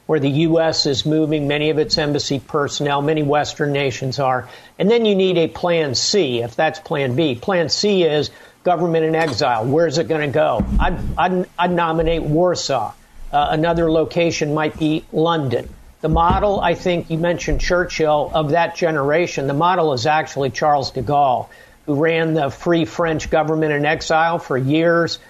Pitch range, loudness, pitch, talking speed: 145-170 Hz, -18 LUFS, 160 Hz, 175 wpm